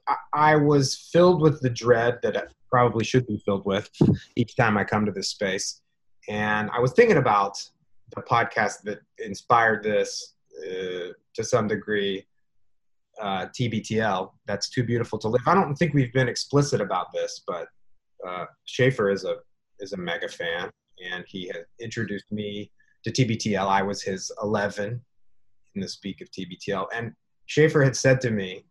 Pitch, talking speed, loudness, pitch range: 120 Hz, 165 wpm, -24 LUFS, 105-150 Hz